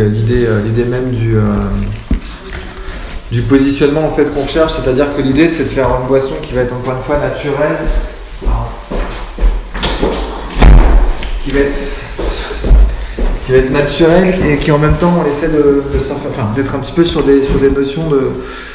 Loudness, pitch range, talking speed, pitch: -13 LUFS, 125-145 Hz, 170 wpm, 140 Hz